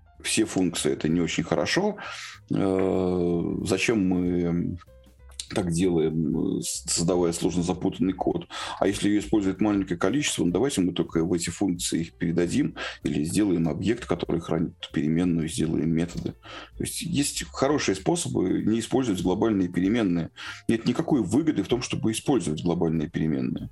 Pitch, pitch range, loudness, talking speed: 90 Hz, 85-95 Hz, -26 LUFS, 140 wpm